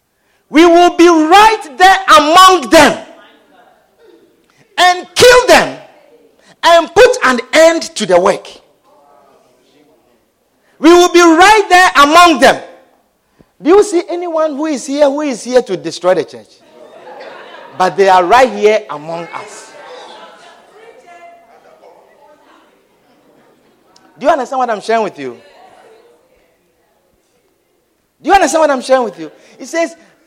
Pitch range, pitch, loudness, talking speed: 255-360 Hz, 325 Hz, -9 LUFS, 125 wpm